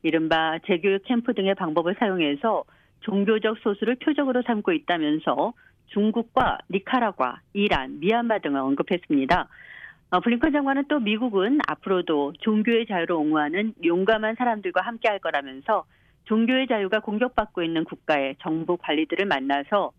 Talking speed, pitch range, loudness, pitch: 345 characters per minute, 170-235 Hz, -24 LUFS, 210 Hz